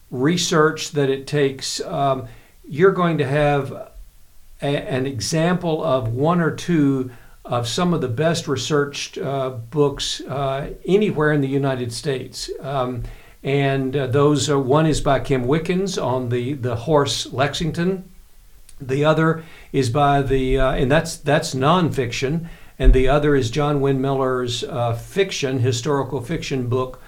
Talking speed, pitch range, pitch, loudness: 145 wpm, 130-155 Hz, 140 Hz, -20 LUFS